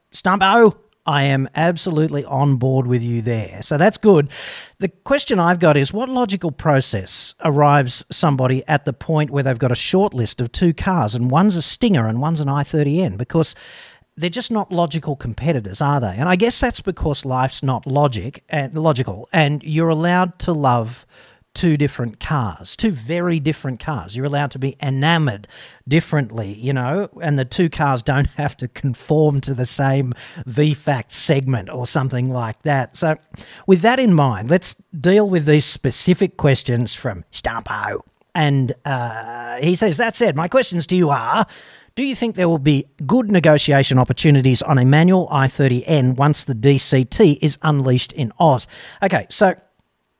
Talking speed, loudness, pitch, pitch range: 170 wpm, -18 LUFS, 145 Hz, 130-170 Hz